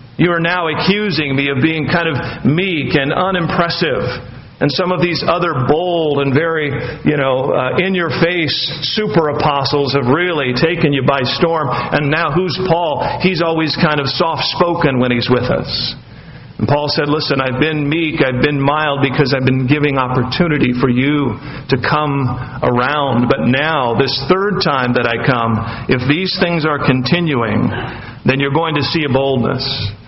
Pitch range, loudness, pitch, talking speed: 130-165 Hz, -15 LUFS, 145 Hz, 175 wpm